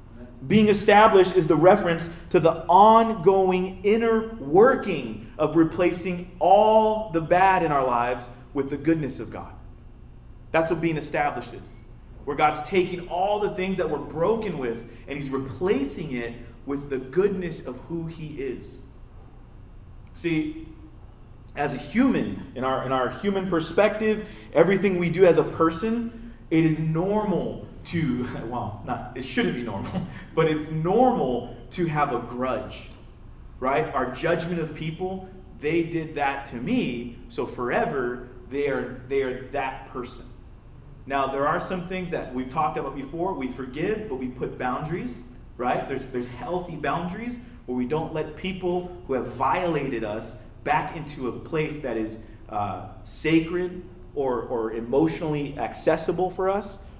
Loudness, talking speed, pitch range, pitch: -24 LUFS, 150 wpm, 125-180 Hz, 150 Hz